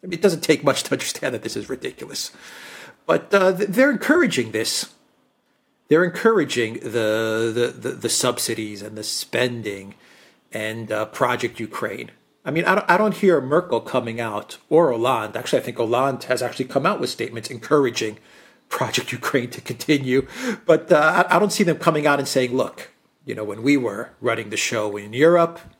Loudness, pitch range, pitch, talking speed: -21 LUFS, 115-180 Hz, 145 Hz, 185 wpm